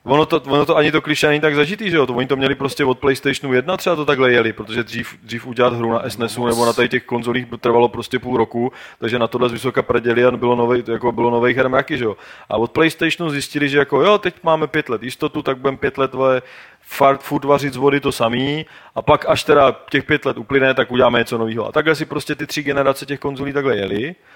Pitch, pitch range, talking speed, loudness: 135 Hz, 120-145 Hz, 250 wpm, -17 LUFS